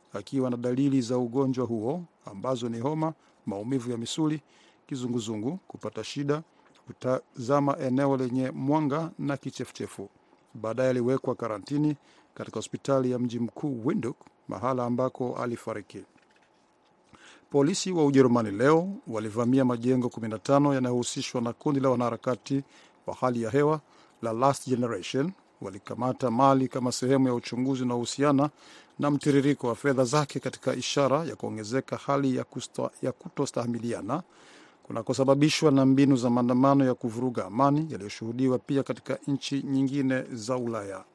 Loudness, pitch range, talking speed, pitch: -28 LUFS, 120-140 Hz, 130 wpm, 130 Hz